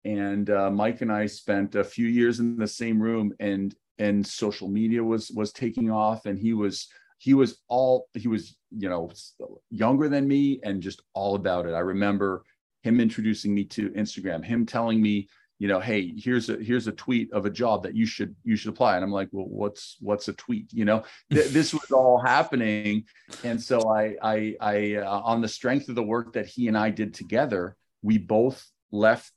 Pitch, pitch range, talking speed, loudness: 110 Hz, 105-120 Hz, 210 wpm, -26 LUFS